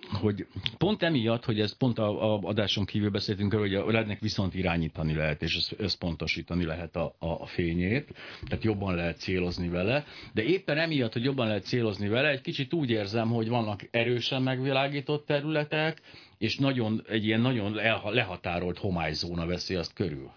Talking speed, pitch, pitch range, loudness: 160 wpm, 110 Hz, 95-125 Hz, -29 LUFS